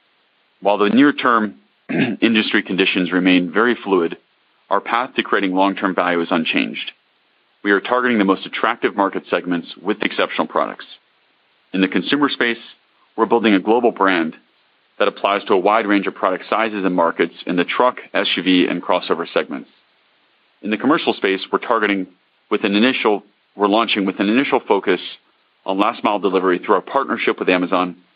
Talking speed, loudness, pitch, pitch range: 170 wpm, -18 LUFS, 95 Hz, 90-110 Hz